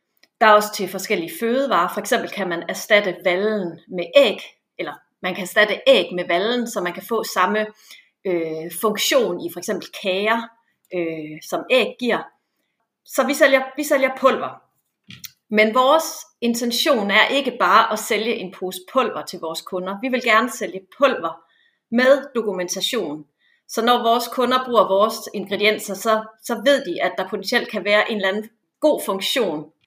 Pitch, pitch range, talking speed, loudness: 215 Hz, 185-245 Hz, 170 wpm, -20 LUFS